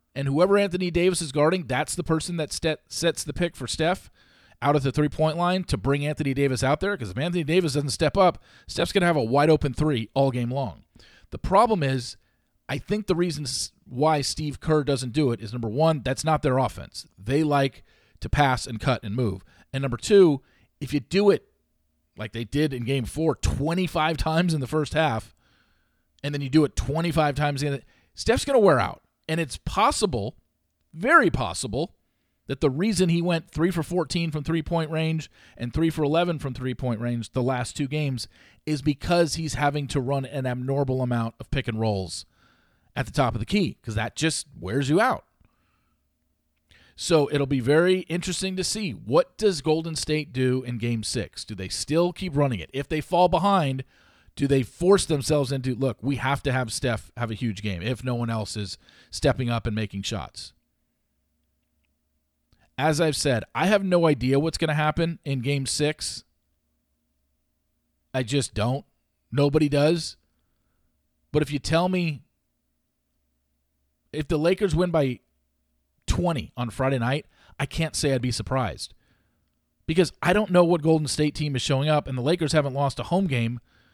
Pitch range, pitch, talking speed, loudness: 115-160 Hz, 140 Hz, 190 wpm, -25 LUFS